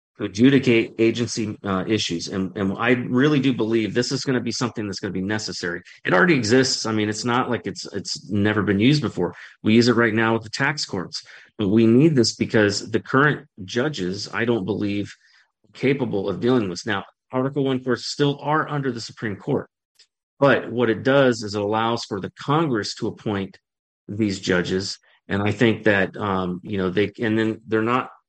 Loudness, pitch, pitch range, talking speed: -22 LUFS, 110 Hz, 100-125 Hz, 205 wpm